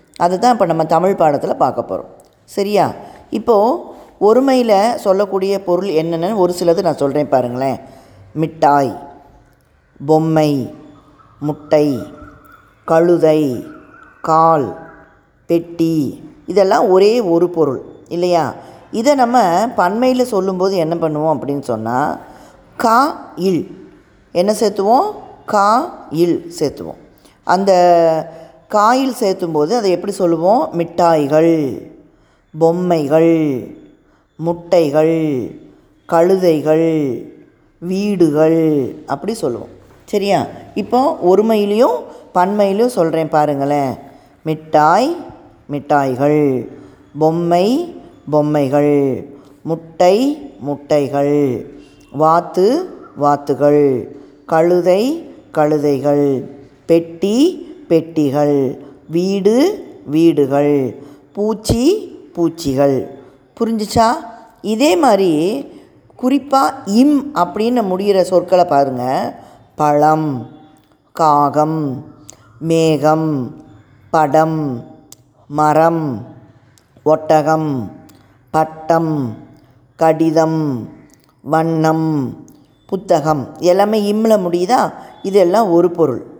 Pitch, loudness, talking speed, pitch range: 160 Hz, -15 LUFS, 75 wpm, 145-190 Hz